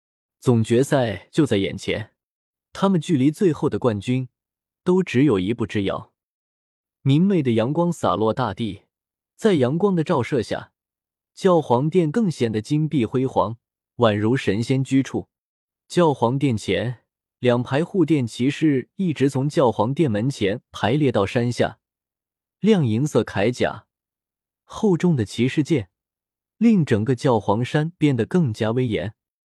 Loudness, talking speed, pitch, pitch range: -21 LUFS, 205 characters per minute, 130 Hz, 110-160 Hz